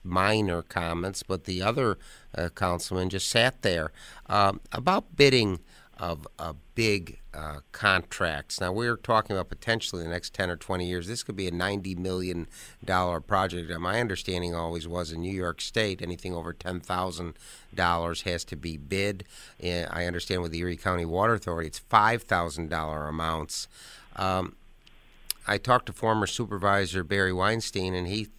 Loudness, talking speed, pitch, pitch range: -28 LUFS, 160 wpm, 90 Hz, 85-100 Hz